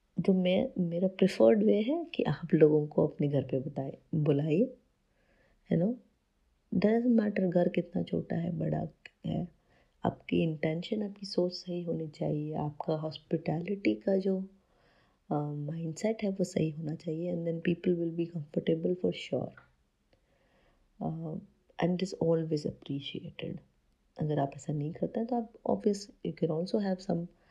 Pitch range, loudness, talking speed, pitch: 155-195 Hz, -32 LUFS, 150 wpm, 170 Hz